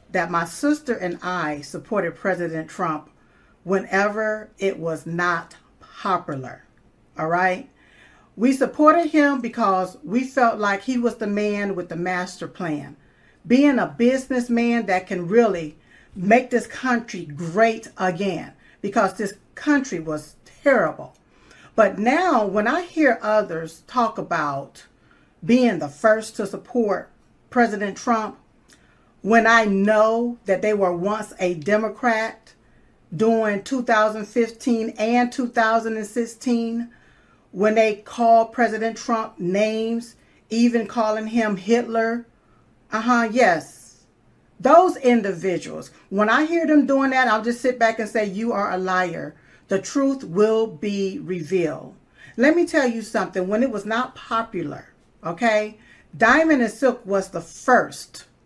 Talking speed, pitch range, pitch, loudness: 130 wpm, 185-235 Hz, 220 Hz, -21 LUFS